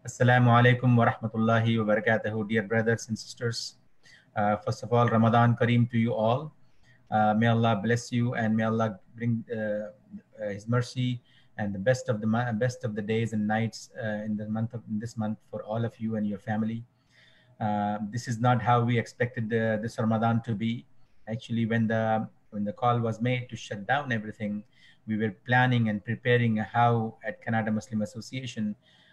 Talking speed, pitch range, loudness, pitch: 185 wpm, 110-120 Hz, -28 LUFS, 115 Hz